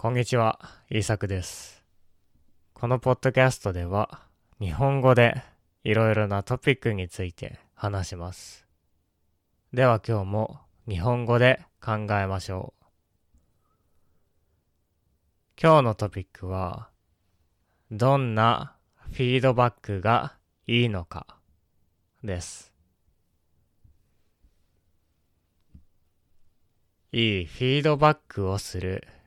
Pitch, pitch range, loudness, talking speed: 100 Hz, 85-115 Hz, -25 LUFS, 195 characters per minute